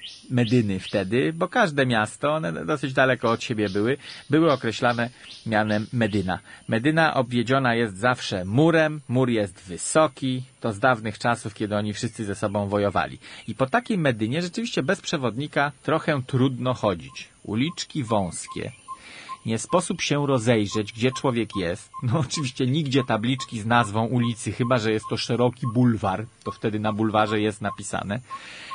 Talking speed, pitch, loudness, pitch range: 150 wpm, 120 Hz, -24 LUFS, 110-140 Hz